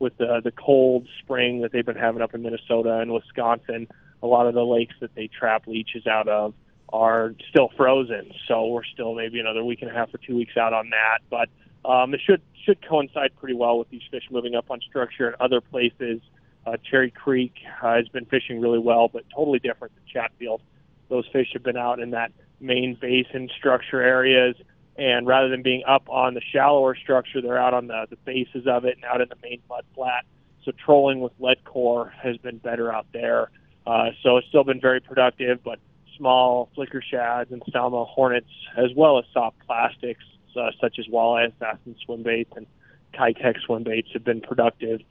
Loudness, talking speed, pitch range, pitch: -23 LUFS, 200 wpm, 115-130 Hz, 125 Hz